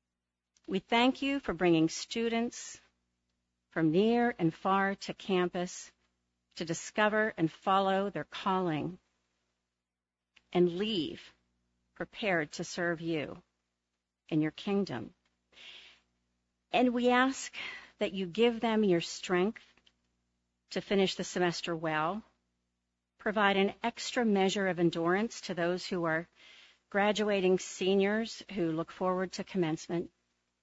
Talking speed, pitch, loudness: 115 wpm, 175 Hz, -31 LUFS